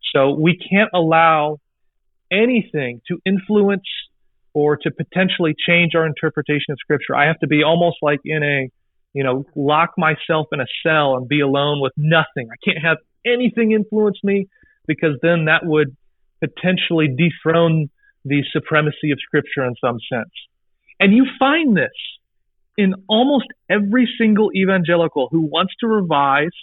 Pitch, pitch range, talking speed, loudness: 160 Hz, 150-190 Hz, 150 wpm, -17 LUFS